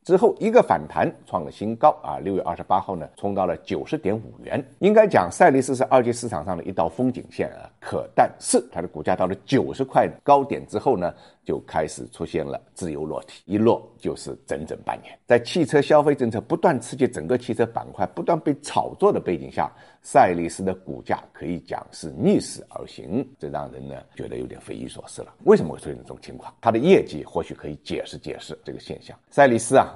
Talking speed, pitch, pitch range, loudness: 325 characters per minute, 115 Hz, 90-135 Hz, -22 LUFS